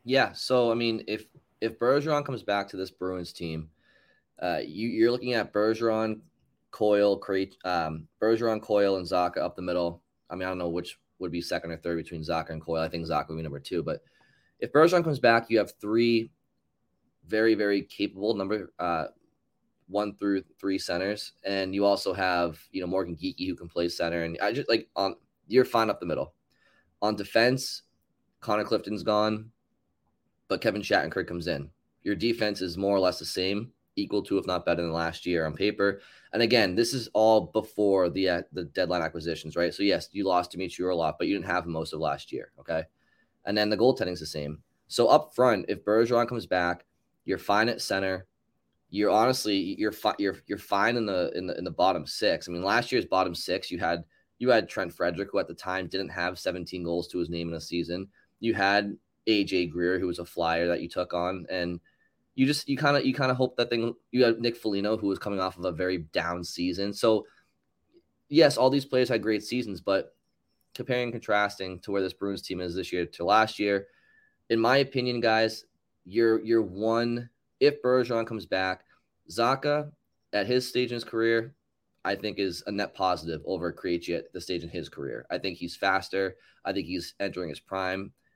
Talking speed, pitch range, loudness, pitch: 210 wpm, 90-115 Hz, -28 LUFS, 100 Hz